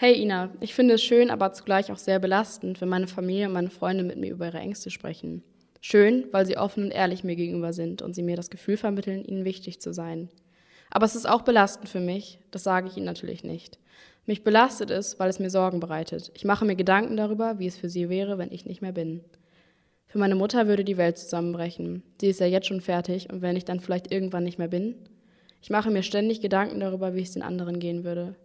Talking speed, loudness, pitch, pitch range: 235 wpm, -26 LUFS, 190 Hz, 175-205 Hz